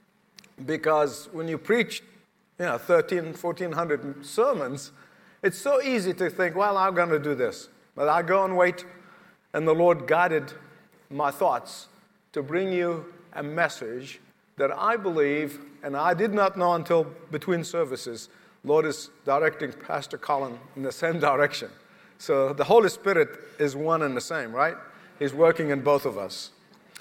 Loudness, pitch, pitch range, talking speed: -25 LUFS, 170 Hz, 150-185 Hz, 160 wpm